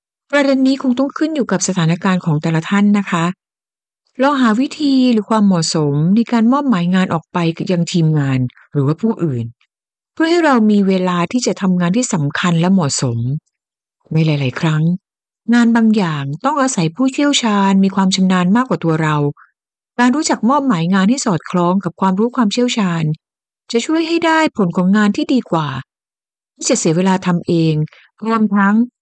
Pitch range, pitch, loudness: 165-245 Hz, 190 Hz, -15 LUFS